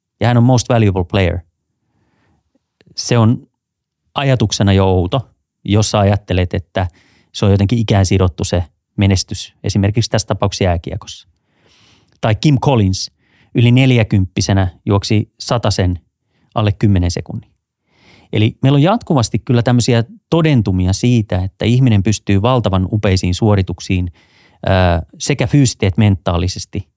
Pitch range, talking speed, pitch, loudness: 95-120 Hz, 120 wpm, 105 Hz, -15 LUFS